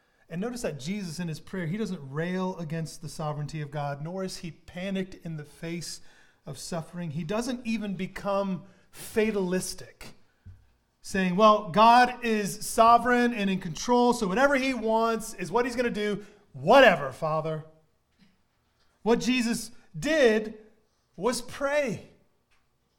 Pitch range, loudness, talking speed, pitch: 165-225 Hz, -26 LUFS, 140 wpm, 195 Hz